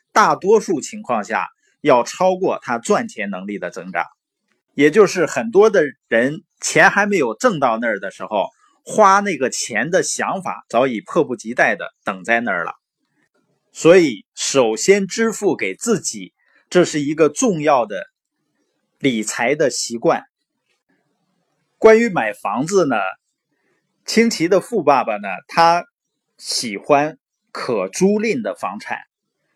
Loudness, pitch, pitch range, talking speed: -17 LUFS, 220 Hz, 185-305 Hz, 195 characters per minute